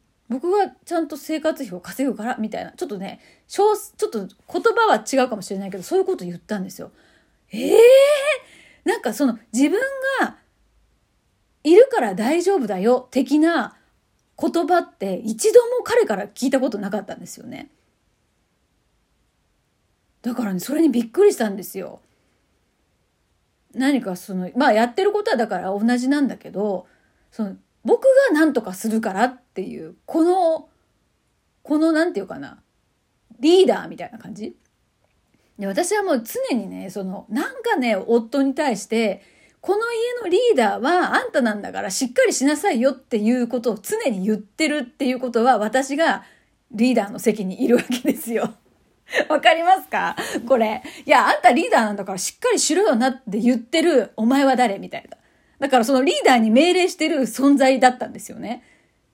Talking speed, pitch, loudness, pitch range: 315 characters per minute, 265 Hz, -20 LUFS, 225-325 Hz